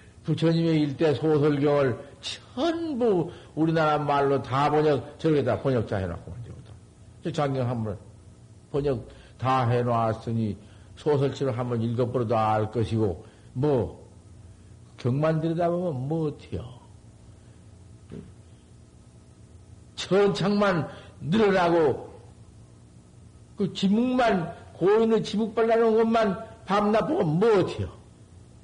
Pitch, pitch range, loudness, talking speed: 130 Hz, 110-165 Hz, -25 LUFS, 205 characters per minute